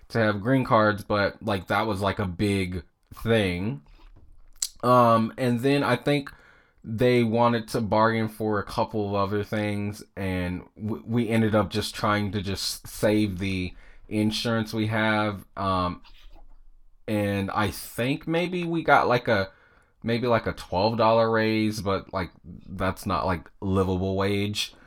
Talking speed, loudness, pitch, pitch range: 150 wpm, -25 LUFS, 105 Hz, 95-115 Hz